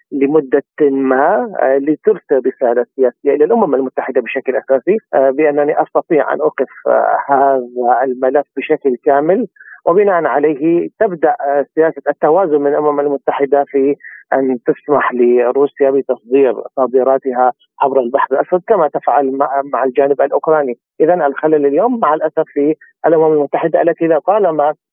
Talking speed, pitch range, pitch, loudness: 120 wpm, 135-155 Hz, 145 Hz, -14 LUFS